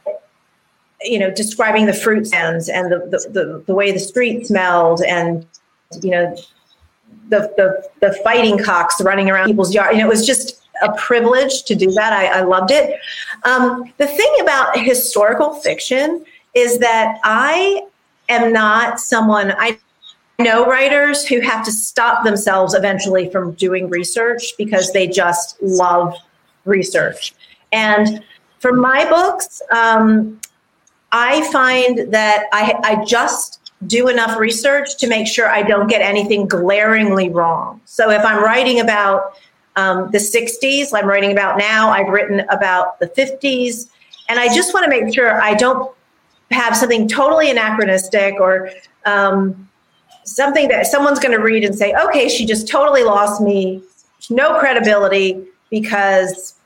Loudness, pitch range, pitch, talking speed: -14 LUFS, 195-250 Hz, 220 Hz, 150 wpm